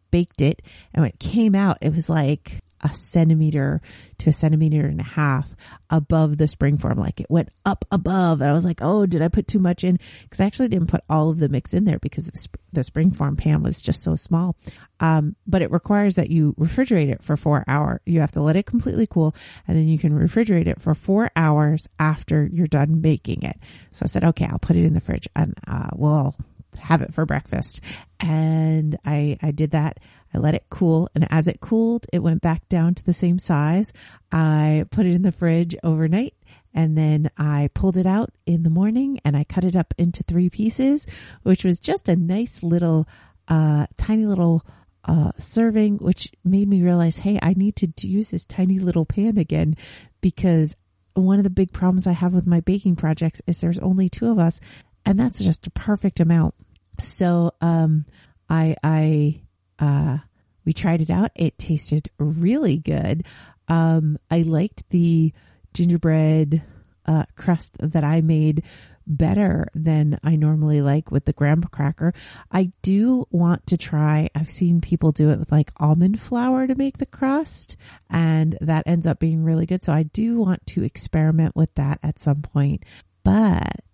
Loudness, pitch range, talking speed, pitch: -20 LUFS, 150-180 Hz, 195 wpm, 160 Hz